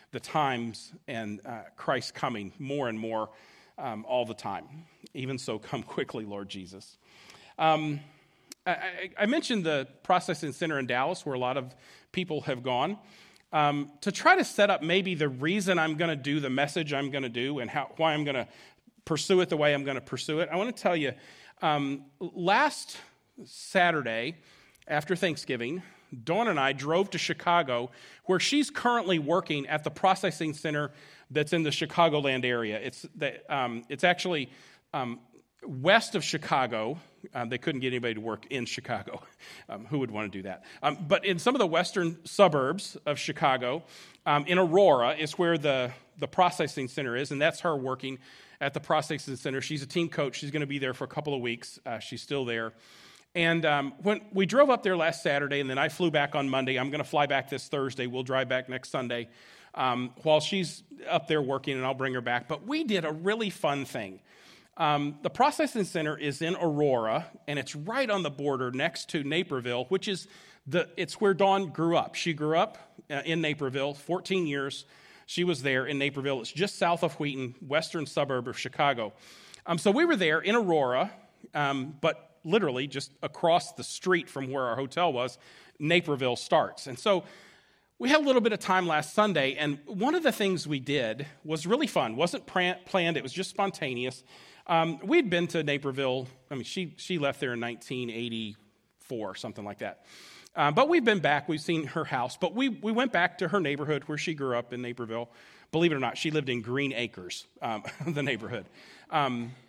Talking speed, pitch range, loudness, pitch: 195 wpm, 130-180 Hz, -29 LUFS, 150 Hz